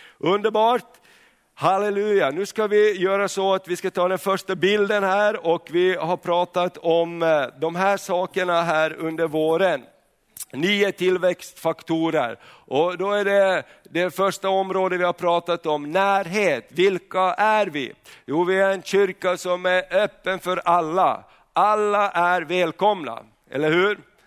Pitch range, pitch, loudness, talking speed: 175-200 Hz, 185 Hz, -21 LUFS, 145 wpm